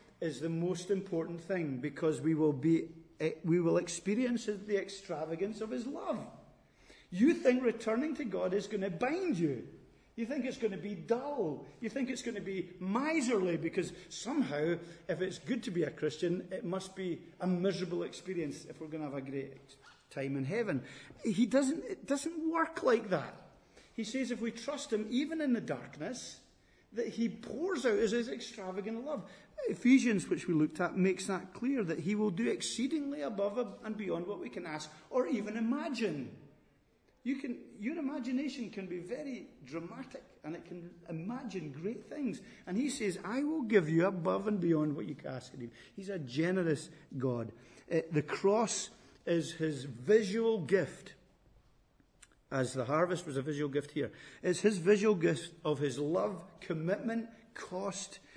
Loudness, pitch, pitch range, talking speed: -35 LUFS, 195 Hz, 165-235 Hz, 175 wpm